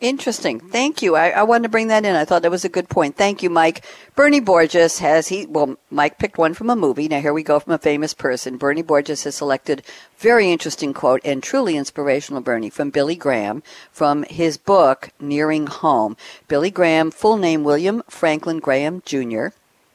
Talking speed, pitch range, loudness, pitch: 200 wpm, 145-185 Hz, -18 LUFS, 160 Hz